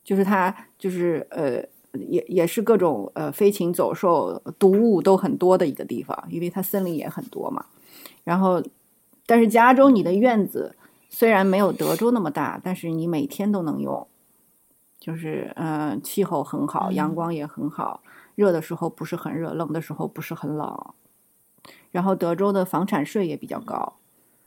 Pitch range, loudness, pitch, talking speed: 165-200 Hz, -23 LUFS, 180 Hz, 250 characters per minute